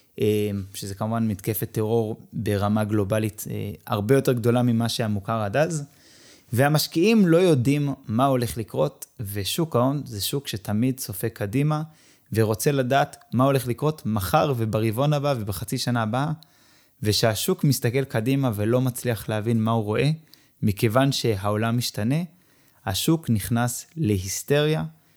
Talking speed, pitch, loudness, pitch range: 125 wpm, 120 Hz, -24 LUFS, 110-140 Hz